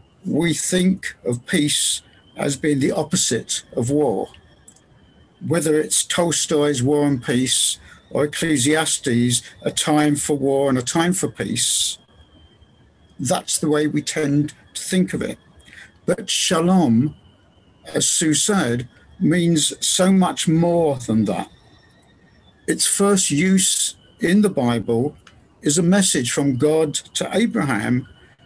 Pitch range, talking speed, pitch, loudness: 125-165 Hz, 125 wpm, 150 Hz, -19 LUFS